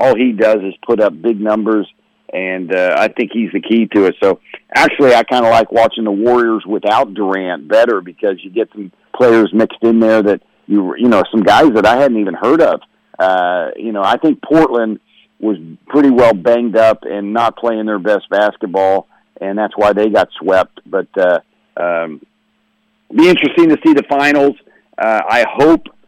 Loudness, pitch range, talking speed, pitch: -13 LUFS, 100-120 Hz, 195 wpm, 110 Hz